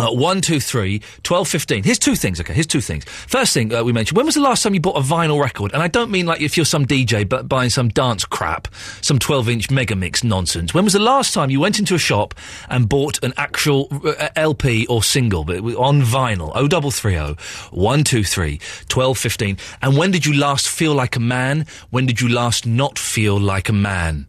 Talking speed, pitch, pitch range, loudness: 230 wpm, 130 Hz, 105-150 Hz, -17 LUFS